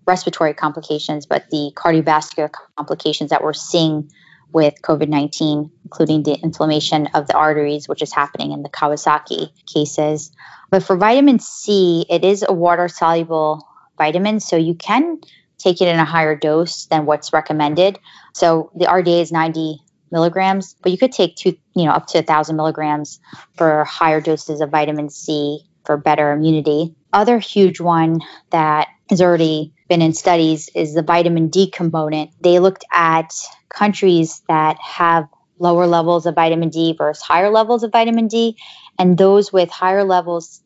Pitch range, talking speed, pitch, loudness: 155-180 Hz, 160 wpm, 165 Hz, -16 LUFS